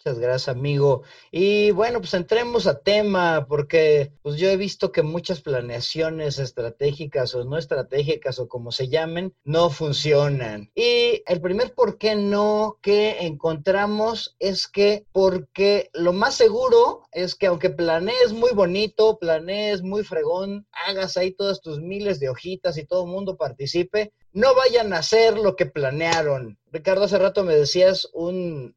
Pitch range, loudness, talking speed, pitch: 155-205 Hz, -21 LUFS, 155 wpm, 185 Hz